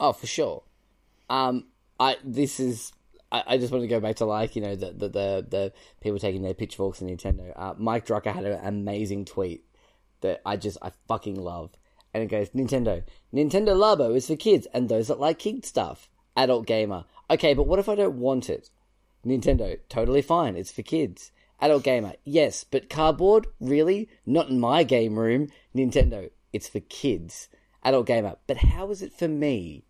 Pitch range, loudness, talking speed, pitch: 100-145 Hz, -26 LUFS, 190 wpm, 120 Hz